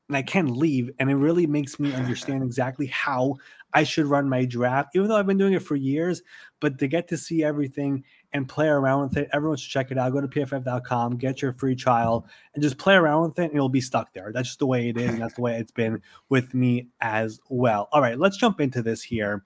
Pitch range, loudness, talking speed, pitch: 125-150 Hz, -24 LUFS, 255 wpm, 135 Hz